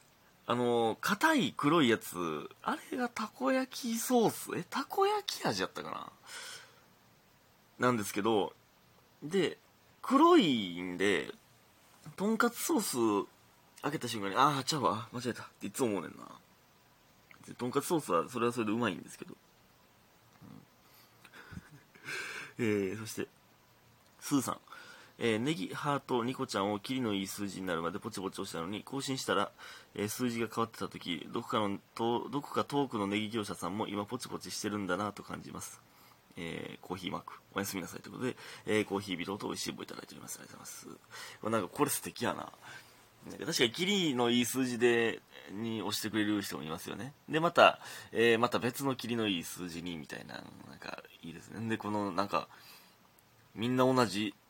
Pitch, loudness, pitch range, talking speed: 115 Hz, -33 LUFS, 105-140 Hz, 345 characters per minute